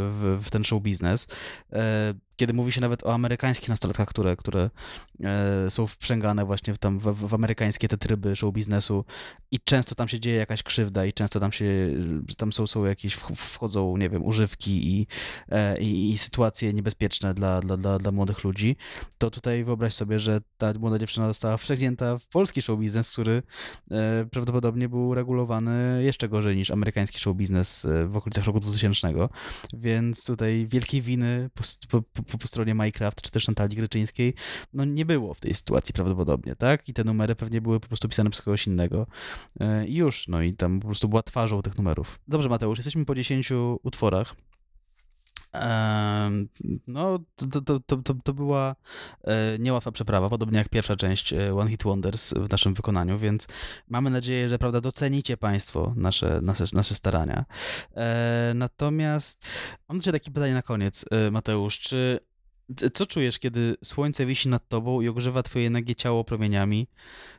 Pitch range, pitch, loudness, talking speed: 100-125 Hz, 110 Hz, -26 LUFS, 165 wpm